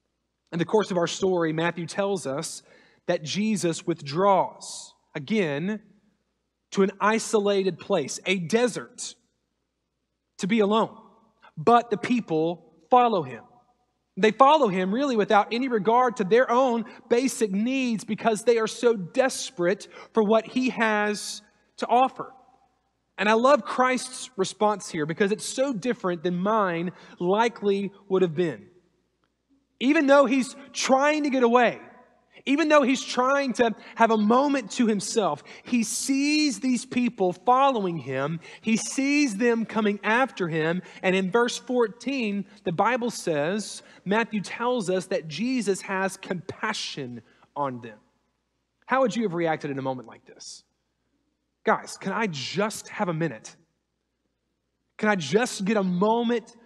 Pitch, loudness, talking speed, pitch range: 215 Hz, -24 LUFS, 140 wpm, 185-240 Hz